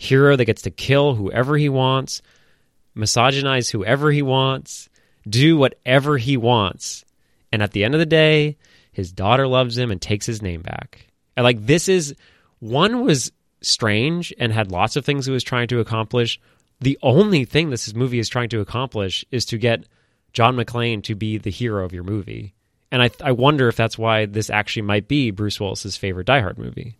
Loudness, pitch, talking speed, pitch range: -19 LUFS, 120 Hz, 190 wpm, 110-135 Hz